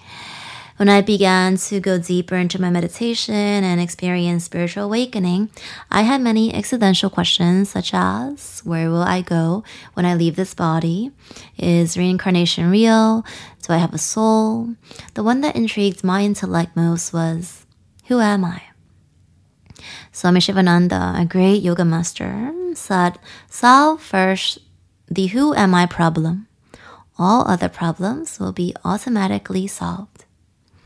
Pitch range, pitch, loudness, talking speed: 170-210 Hz, 185 Hz, -18 LUFS, 135 wpm